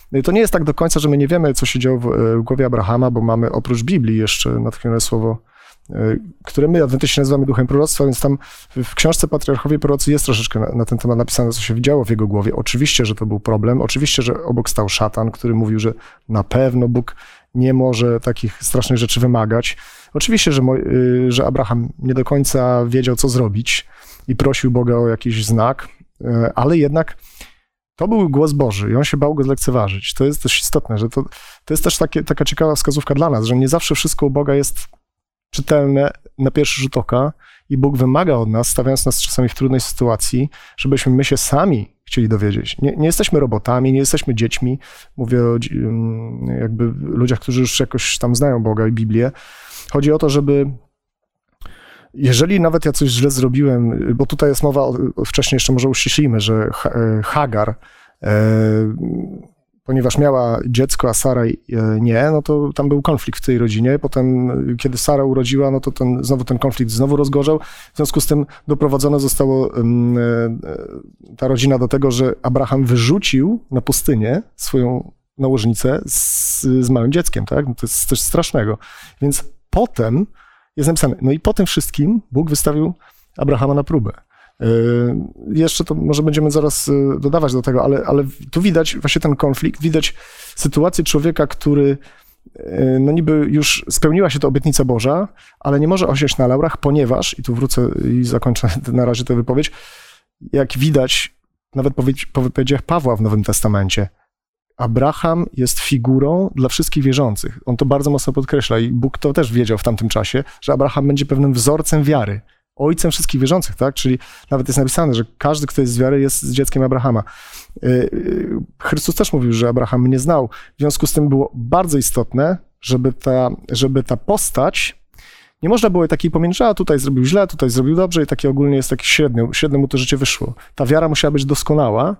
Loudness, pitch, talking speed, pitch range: -16 LUFS, 135 Hz, 180 wpm, 120-145 Hz